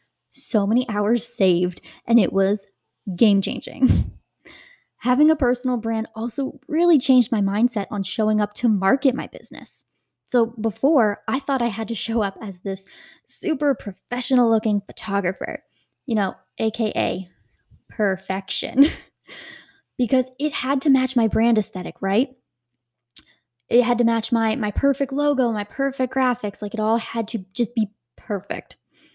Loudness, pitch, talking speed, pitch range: -22 LUFS, 225 Hz, 150 wpm, 205-255 Hz